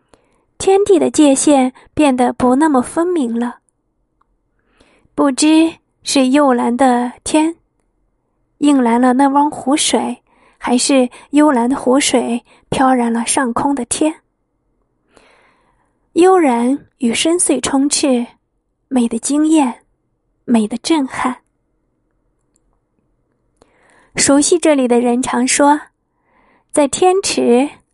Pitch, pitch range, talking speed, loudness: 275 Hz, 245-310 Hz, 145 characters per minute, -14 LUFS